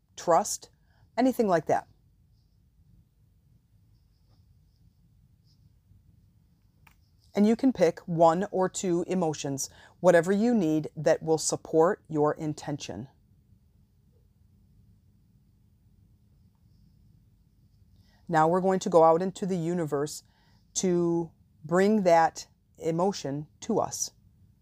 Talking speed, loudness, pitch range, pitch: 85 wpm, -26 LUFS, 100-170 Hz, 150 Hz